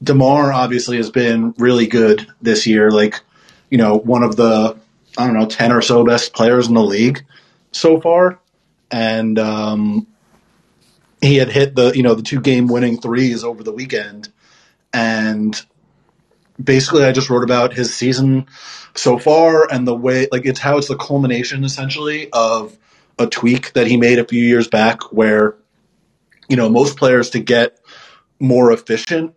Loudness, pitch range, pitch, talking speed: -14 LUFS, 115-135 Hz, 125 Hz, 170 wpm